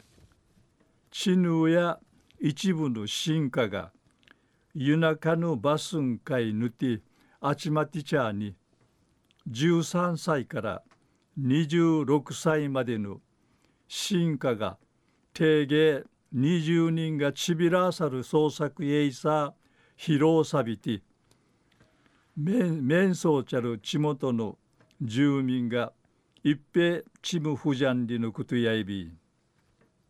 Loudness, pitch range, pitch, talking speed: -27 LUFS, 130-160 Hz, 150 Hz, 170 characters per minute